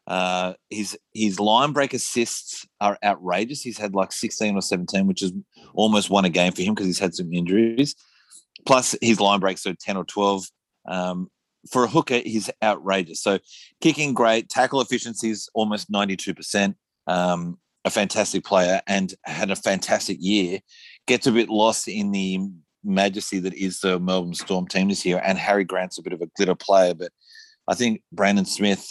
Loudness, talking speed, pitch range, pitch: -22 LUFS, 180 wpm, 95-110 Hz, 100 Hz